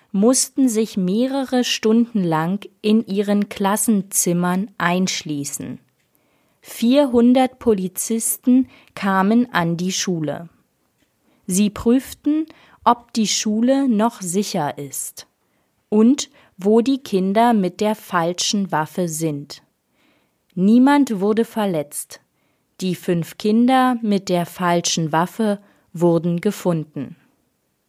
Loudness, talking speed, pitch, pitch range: -19 LUFS, 95 wpm, 205 Hz, 175-235 Hz